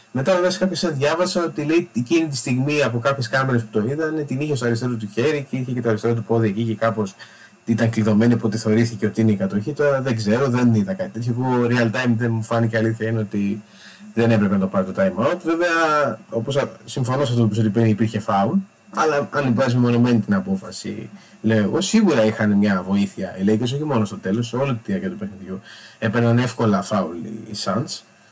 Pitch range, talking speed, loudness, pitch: 110-140 Hz, 220 wpm, -20 LUFS, 115 Hz